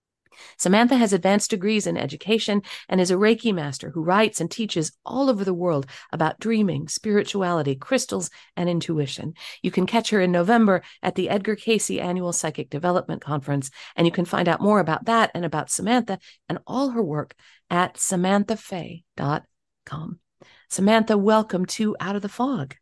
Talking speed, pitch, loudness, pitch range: 165 wpm, 185 Hz, -23 LUFS, 170-215 Hz